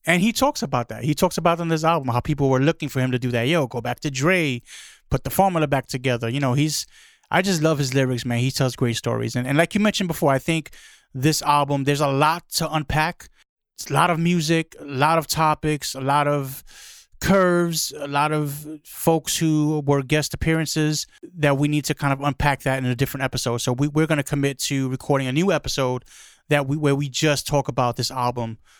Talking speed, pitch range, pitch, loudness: 230 wpm, 130-160 Hz, 145 Hz, -22 LUFS